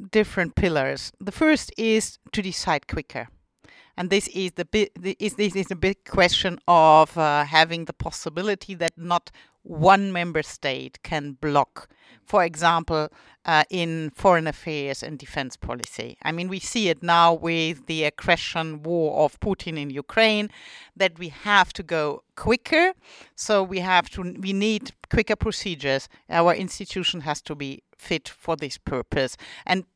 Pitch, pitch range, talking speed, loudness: 170 Hz, 155-195 Hz, 160 wpm, -23 LUFS